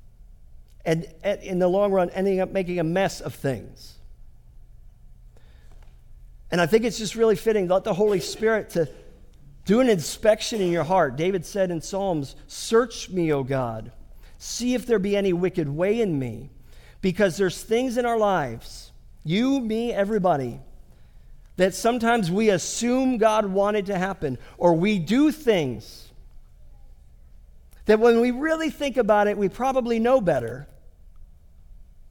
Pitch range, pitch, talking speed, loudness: 135-220 Hz, 190 Hz, 150 wpm, -23 LUFS